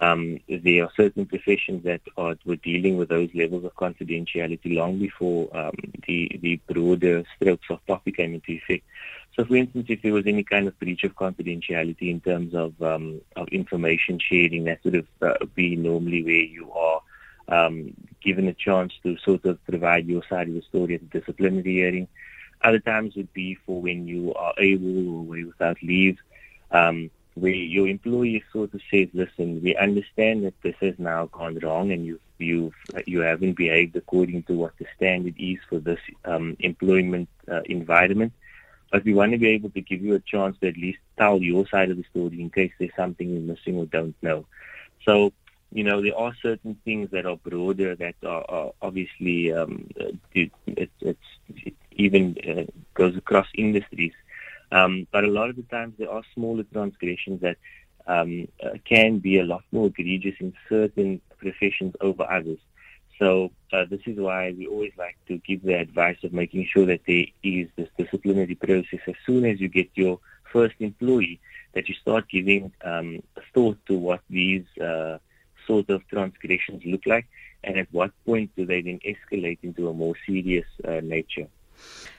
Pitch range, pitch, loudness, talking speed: 85-100 Hz, 90 Hz, -24 LUFS, 185 wpm